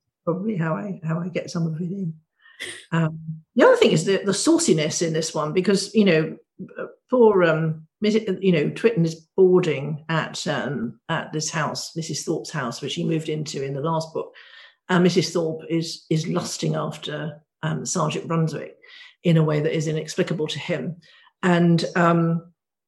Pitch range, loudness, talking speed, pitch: 160-185 Hz, -22 LUFS, 180 wpm, 165 Hz